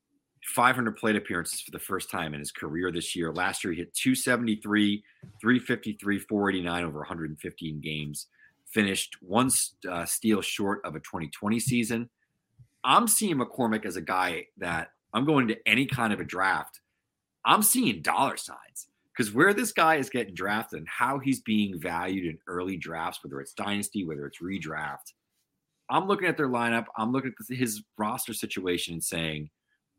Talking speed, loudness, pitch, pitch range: 170 wpm, -28 LUFS, 105 Hz, 90-125 Hz